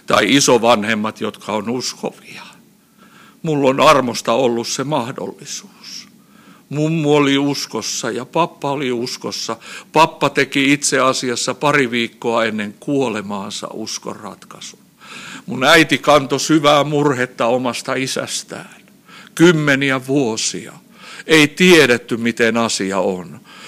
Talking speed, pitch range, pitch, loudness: 105 wpm, 120-150 Hz, 140 Hz, -16 LUFS